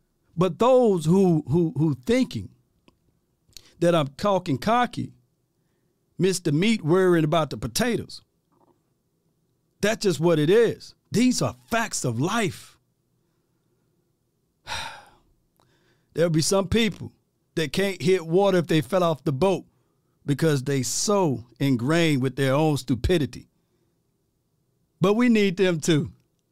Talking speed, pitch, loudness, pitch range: 120 wpm, 165 Hz, -23 LUFS, 145-190 Hz